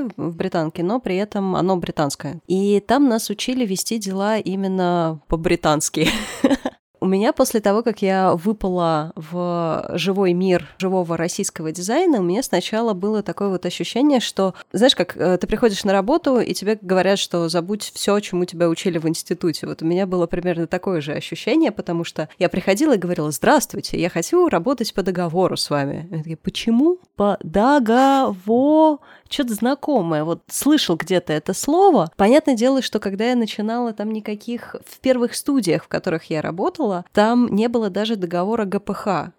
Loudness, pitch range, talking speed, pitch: -20 LUFS, 175-235 Hz, 165 wpm, 195 Hz